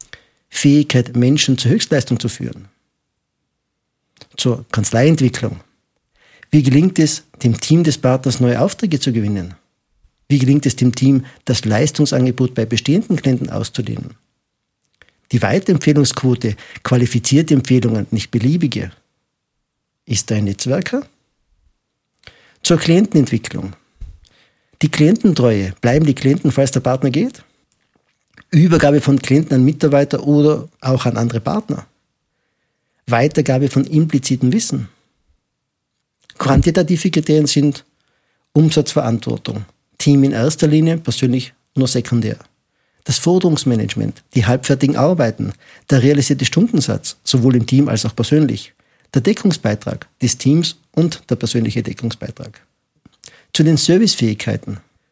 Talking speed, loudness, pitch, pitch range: 110 wpm, -15 LUFS, 135 Hz, 120-150 Hz